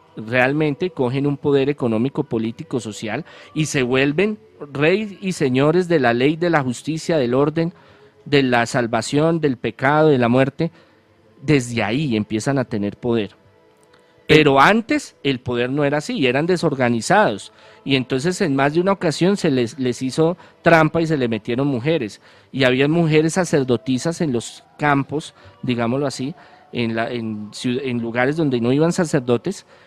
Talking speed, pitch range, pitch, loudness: 160 wpm, 120-160 Hz, 140 Hz, -19 LUFS